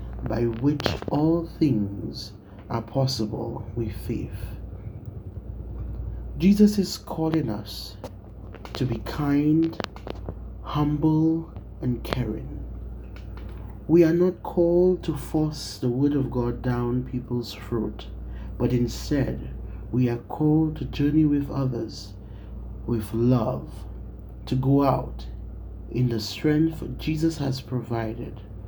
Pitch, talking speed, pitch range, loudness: 120 Hz, 105 wpm, 100-145 Hz, -25 LUFS